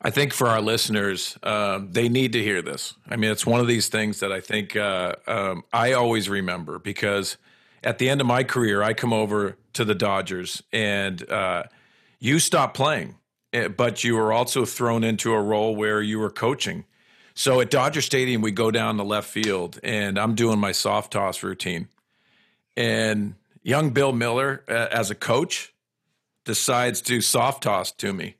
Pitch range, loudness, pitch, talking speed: 105-120 Hz, -23 LUFS, 110 Hz, 185 wpm